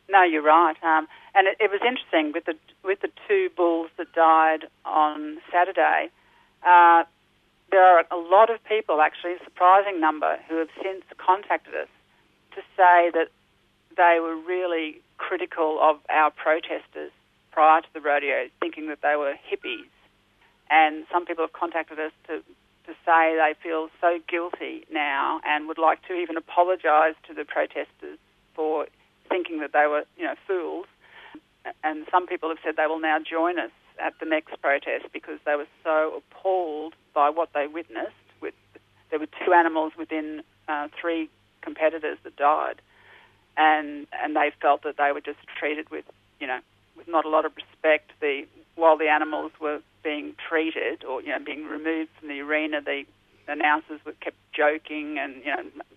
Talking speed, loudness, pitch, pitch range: 170 wpm, -24 LUFS, 160 Hz, 155-180 Hz